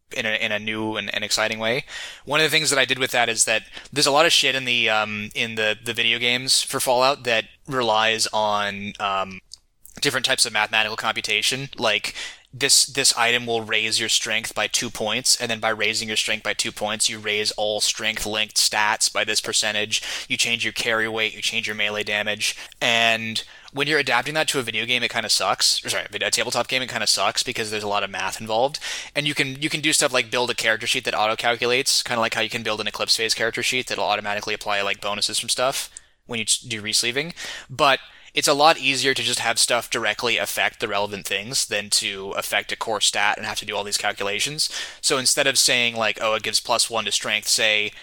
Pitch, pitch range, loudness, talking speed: 115 Hz, 105-125 Hz, -21 LUFS, 235 wpm